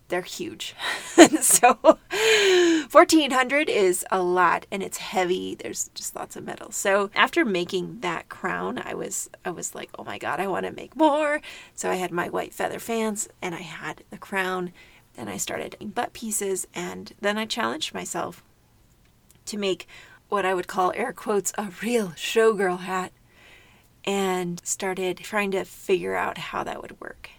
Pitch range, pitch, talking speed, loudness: 185-265 Hz, 200 Hz, 170 wpm, -24 LUFS